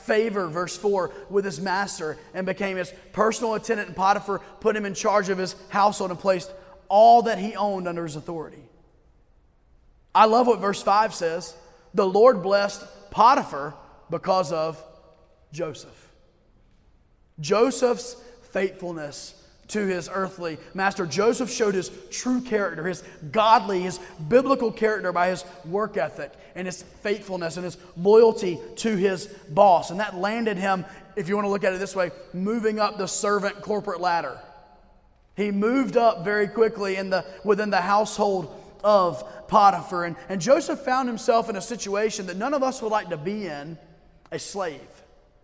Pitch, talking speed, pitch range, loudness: 195 Hz, 160 wpm, 180-215 Hz, -23 LUFS